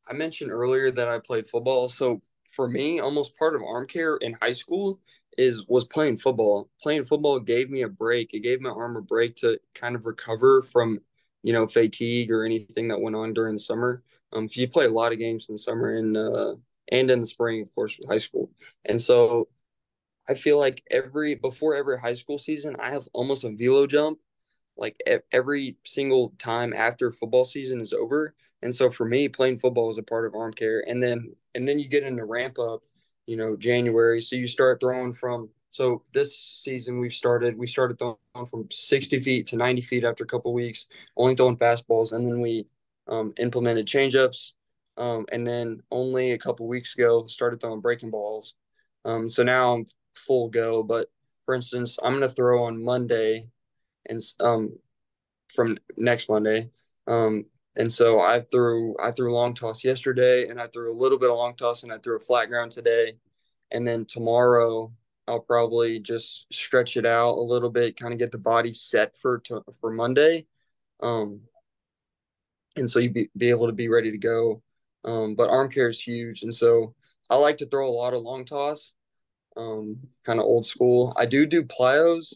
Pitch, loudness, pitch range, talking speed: 120 Hz, -24 LUFS, 115-130 Hz, 200 wpm